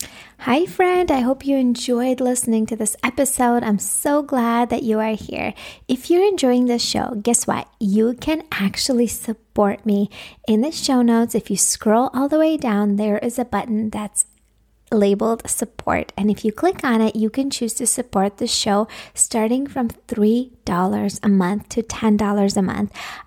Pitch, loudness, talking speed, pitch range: 230 Hz, -19 LUFS, 180 wpm, 210-255 Hz